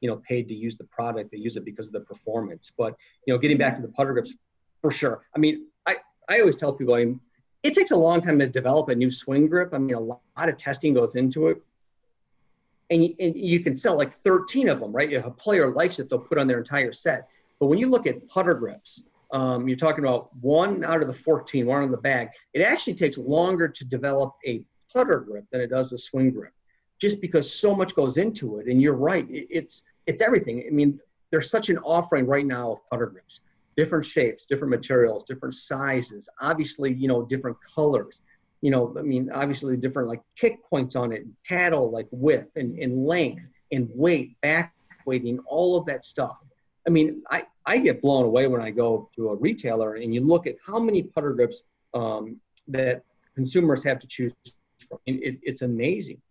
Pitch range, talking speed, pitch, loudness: 125-165 Hz, 220 wpm, 140 Hz, -24 LUFS